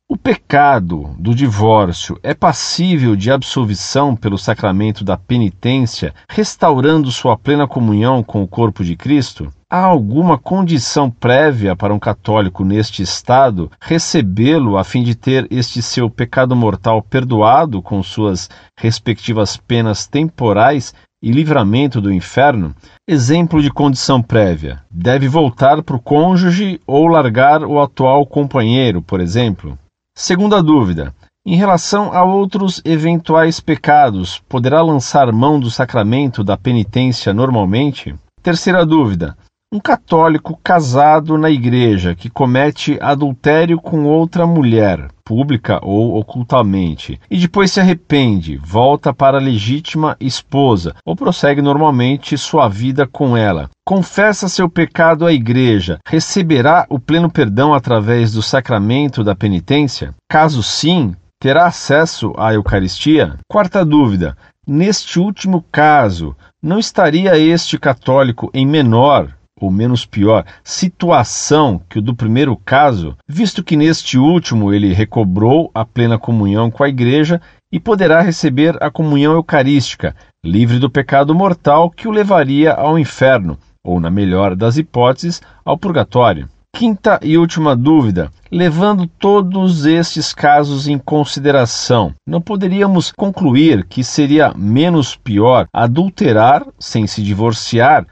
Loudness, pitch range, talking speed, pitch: -13 LUFS, 110-160 Hz, 125 wpm, 135 Hz